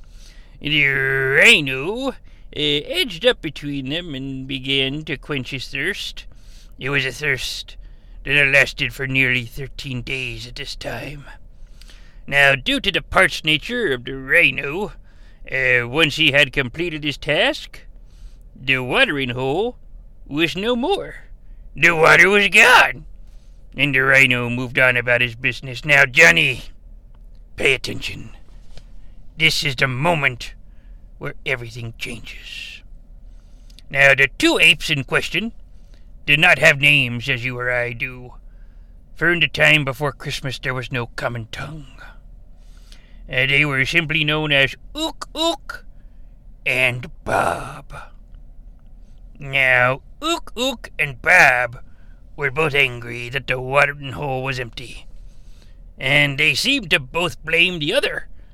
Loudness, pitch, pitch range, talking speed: -17 LUFS, 135 Hz, 120-150 Hz, 135 wpm